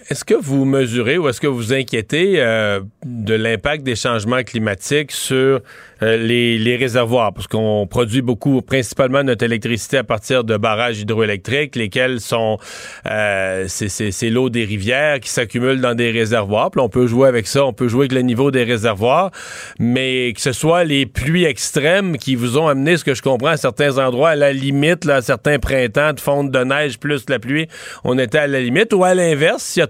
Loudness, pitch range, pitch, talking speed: -16 LUFS, 115-140 Hz, 130 Hz, 205 wpm